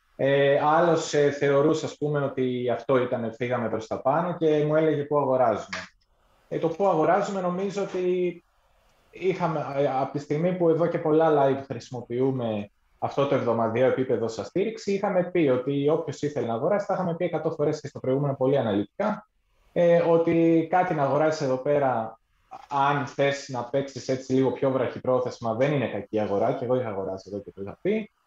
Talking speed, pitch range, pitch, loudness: 170 wpm, 125-165 Hz, 140 Hz, -25 LUFS